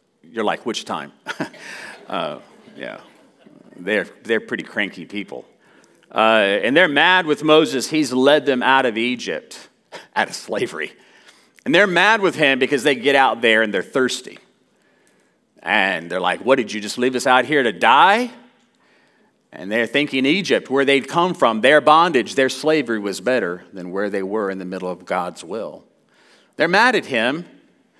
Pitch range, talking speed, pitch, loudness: 105-150 Hz, 170 wpm, 130 Hz, -18 LUFS